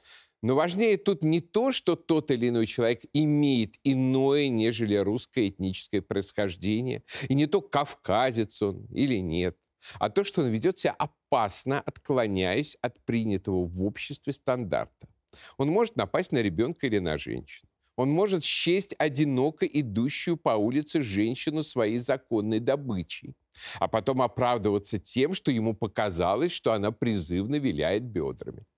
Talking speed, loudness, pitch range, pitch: 140 wpm, -28 LUFS, 105-150 Hz, 125 Hz